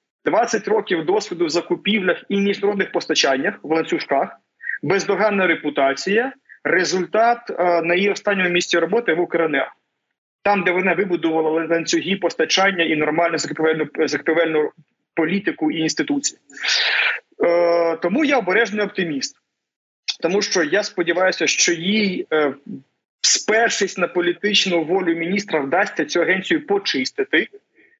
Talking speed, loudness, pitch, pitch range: 120 wpm, -19 LUFS, 180 Hz, 165-210 Hz